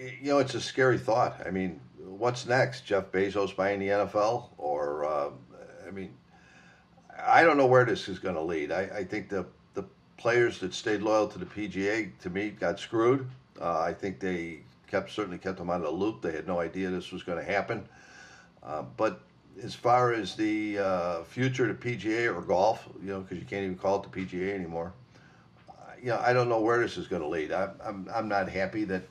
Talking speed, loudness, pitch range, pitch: 220 wpm, -29 LUFS, 95-120 Hz, 100 Hz